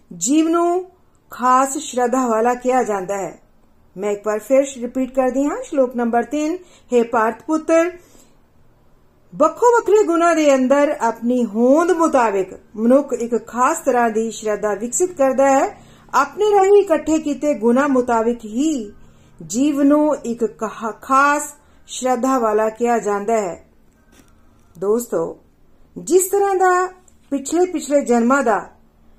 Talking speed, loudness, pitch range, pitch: 125 wpm, -18 LUFS, 225-305 Hz, 260 Hz